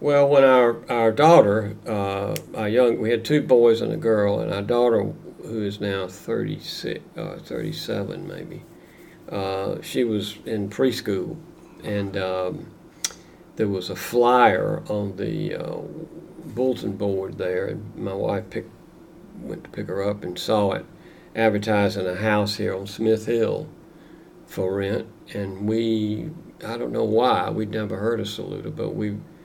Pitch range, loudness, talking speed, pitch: 100-120 Hz, -23 LUFS, 155 wpm, 105 Hz